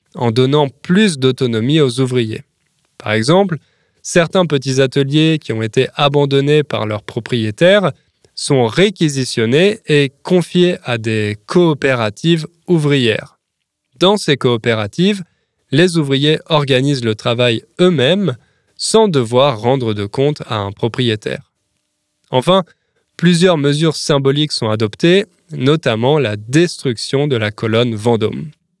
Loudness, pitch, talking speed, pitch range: -14 LUFS, 140 Hz, 115 wpm, 120-165 Hz